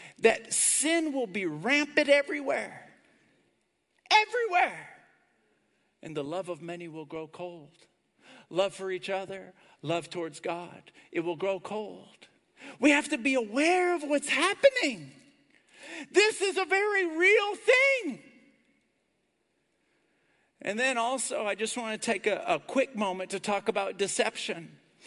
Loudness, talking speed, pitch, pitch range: -27 LUFS, 135 wpm, 250 Hz, 185-310 Hz